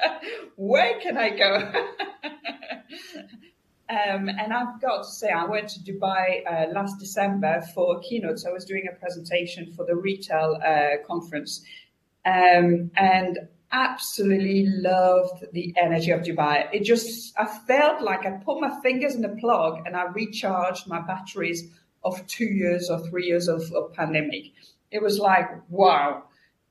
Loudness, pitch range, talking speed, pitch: -24 LUFS, 175-215 Hz, 155 wpm, 190 Hz